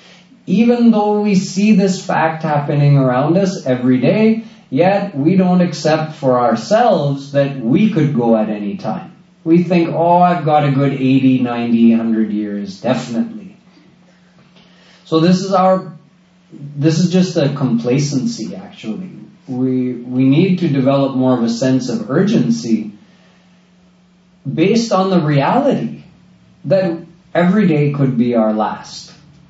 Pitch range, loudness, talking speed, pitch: 130-185 Hz, -14 LUFS, 140 wpm, 165 Hz